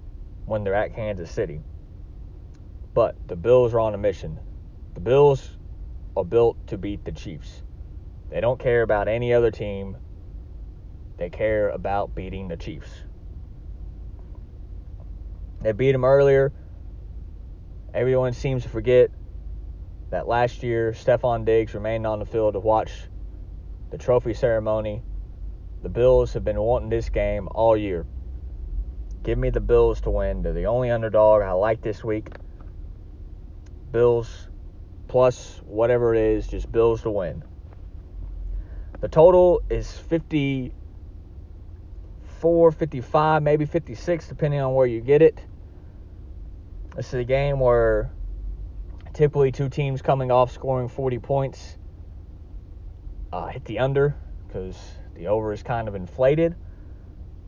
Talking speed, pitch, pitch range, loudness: 130 wpm, 95 Hz, 85-120 Hz, -22 LUFS